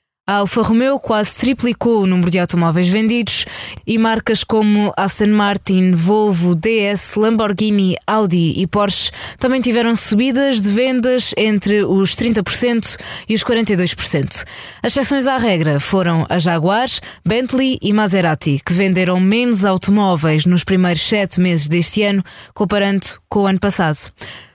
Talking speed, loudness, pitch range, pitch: 140 wpm, -15 LUFS, 180-225 Hz, 205 Hz